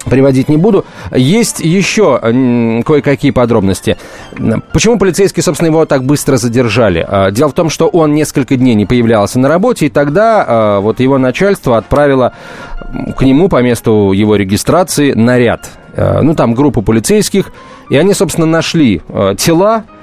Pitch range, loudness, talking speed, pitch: 115-165 Hz, -10 LUFS, 140 wpm, 135 Hz